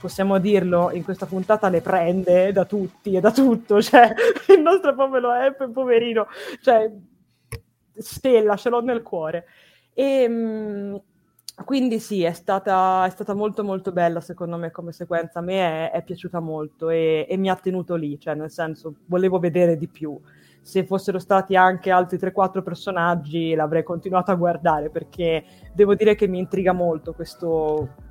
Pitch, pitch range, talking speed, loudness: 185 Hz, 170-205 Hz, 160 wpm, -21 LUFS